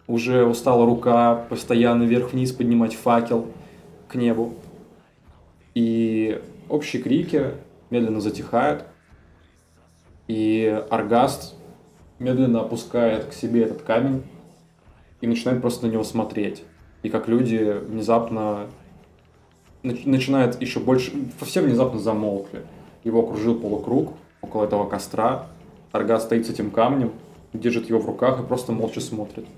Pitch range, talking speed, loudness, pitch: 105-120 Hz, 115 wpm, -22 LUFS, 115 Hz